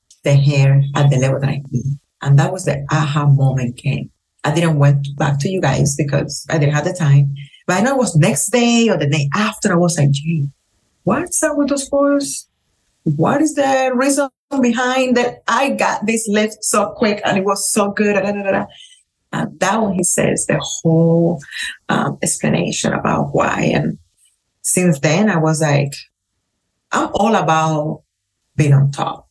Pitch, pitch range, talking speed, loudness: 160 Hz, 140-215 Hz, 180 wpm, -16 LUFS